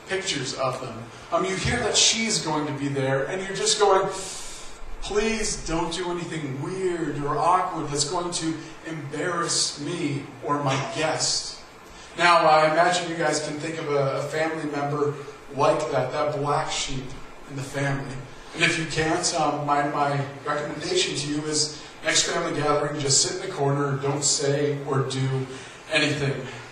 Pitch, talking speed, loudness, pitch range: 150 Hz, 170 wpm, -24 LUFS, 140-170 Hz